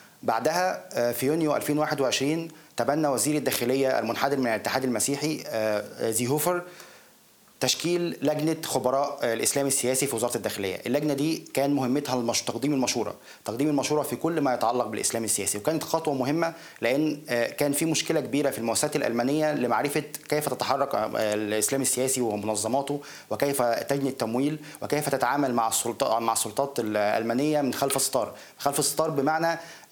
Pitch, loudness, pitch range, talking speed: 140 Hz, -26 LUFS, 120-150 Hz, 135 wpm